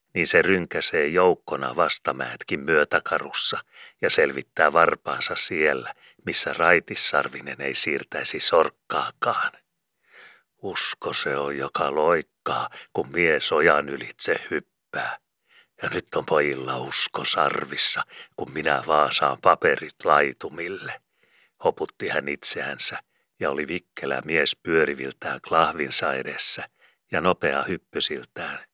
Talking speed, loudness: 100 wpm, -22 LUFS